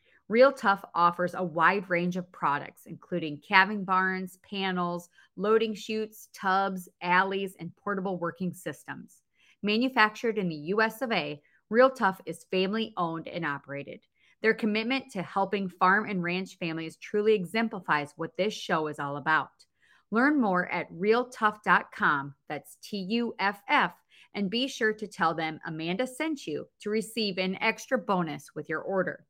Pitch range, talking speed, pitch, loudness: 175-220 Hz, 150 wpm, 190 Hz, -28 LUFS